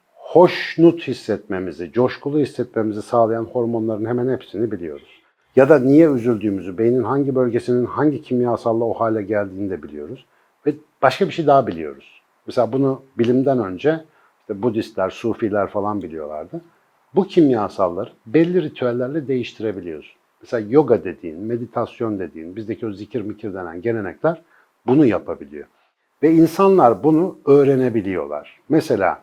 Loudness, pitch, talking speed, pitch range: -19 LUFS, 120 Hz, 125 wpm, 110-145 Hz